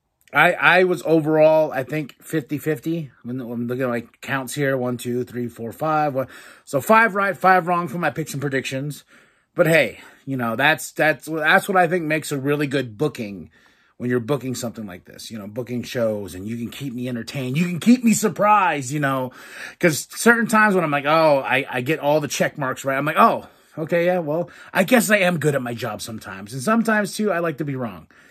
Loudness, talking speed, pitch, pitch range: -20 LUFS, 225 wpm, 145 Hz, 125-170 Hz